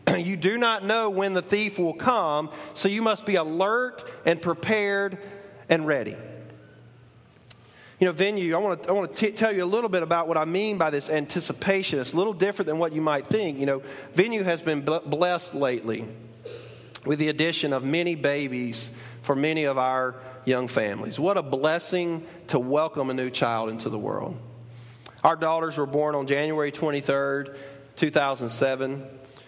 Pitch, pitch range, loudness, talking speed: 155 Hz, 135-180 Hz, -25 LUFS, 175 wpm